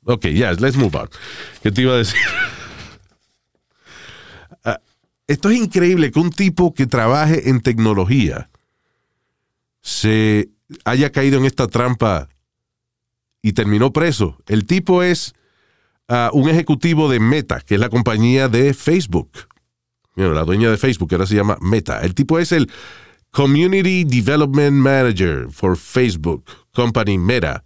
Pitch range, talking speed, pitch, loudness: 105-145 Hz, 140 wpm, 125 Hz, -16 LUFS